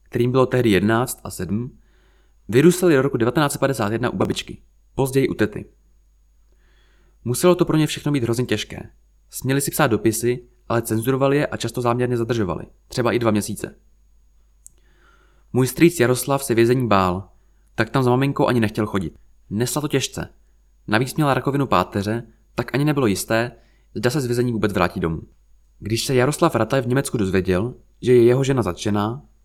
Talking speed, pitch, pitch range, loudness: 165 wpm, 120 Hz, 100-130 Hz, -20 LUFS